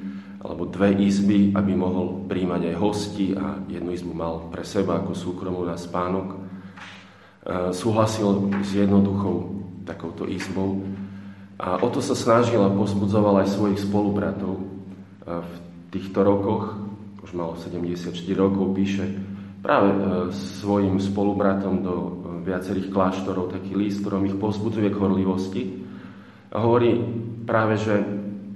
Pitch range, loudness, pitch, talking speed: 95-100 Hz, -24 LUFS, 95 Hz, 120 wpm